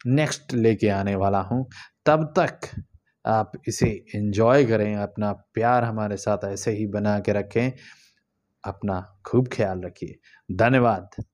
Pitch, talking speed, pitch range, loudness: 110 Hz, 130 wpm, 100-125 Hz, -24 LUFS